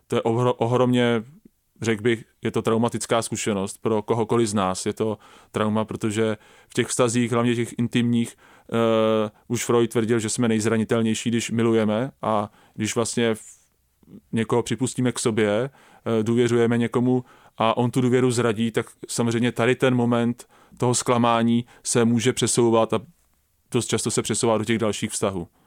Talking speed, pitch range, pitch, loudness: 155 wpm, 110-120 Hz, 115 Hz, -23 LUFS